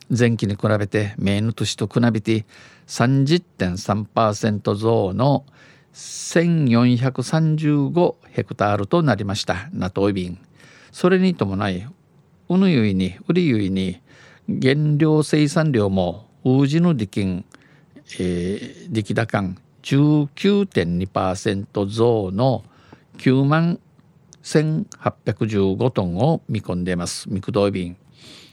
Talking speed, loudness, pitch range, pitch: 175 characters per minute, -20 LUFS, 100-150 Hz, 120 Hz